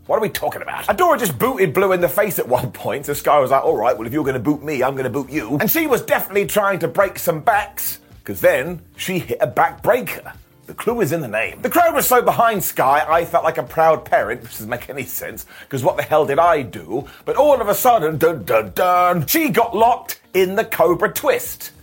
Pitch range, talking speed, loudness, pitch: 155-225 Hz, 245 wpm, -18 LUFS, 185 Hz